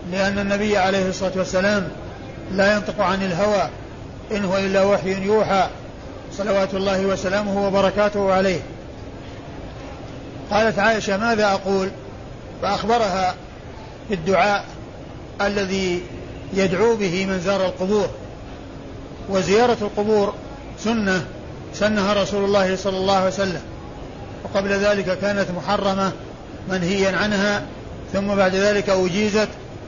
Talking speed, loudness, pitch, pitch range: 100 wpm, -20 LUFS, 195 Hz, 185-205 Hz